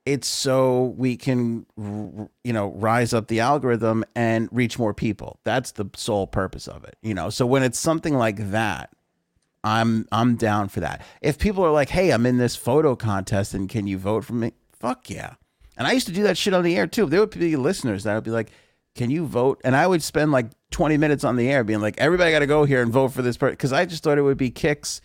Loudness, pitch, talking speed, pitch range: -22 LUFS, 120 Hz, 245 wpm, 110-145 Hz